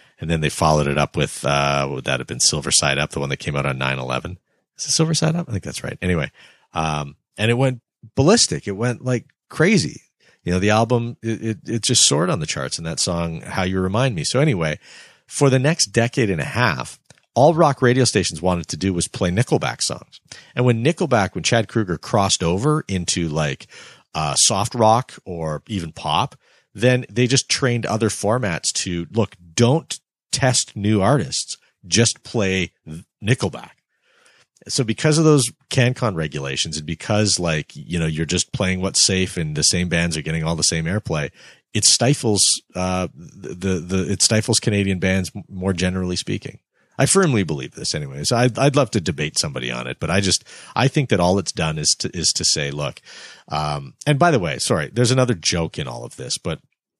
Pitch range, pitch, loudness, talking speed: 85-125 Hz, 100 Hz, -19 LUFS, 205 wpm